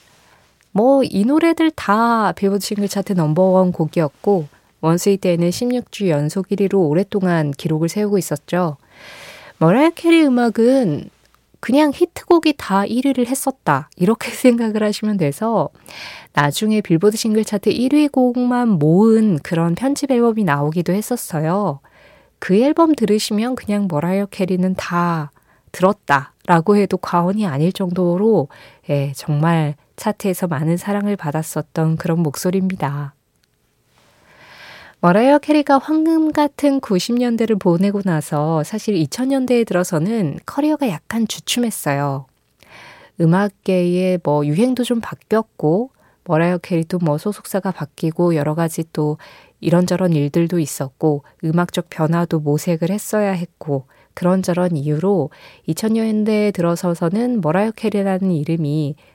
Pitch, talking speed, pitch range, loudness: 185 Hz, 290 characters per minute, 165-220 Hz, -18 LUFS